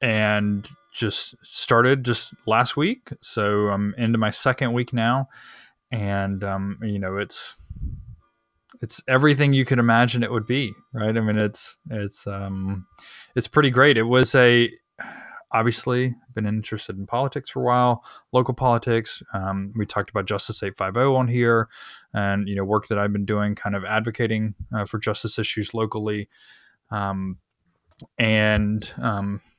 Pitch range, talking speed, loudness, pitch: 100-120 Hz, 150 wpm, -22 LUFS, 110 Hz